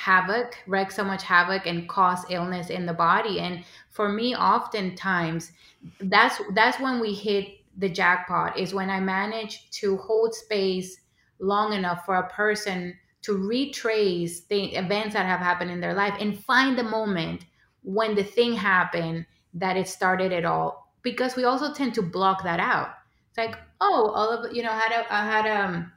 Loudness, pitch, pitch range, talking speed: -25 LUFS, 195 Hz, 180-220 Hz, 180 wpm